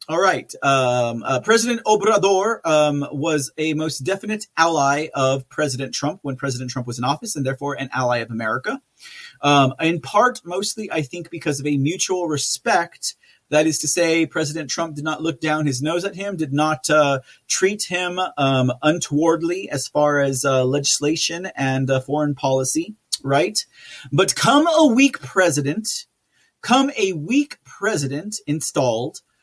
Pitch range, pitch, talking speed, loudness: 140-185 Hz, 155 Hz, 160 wpm, -20 LUFS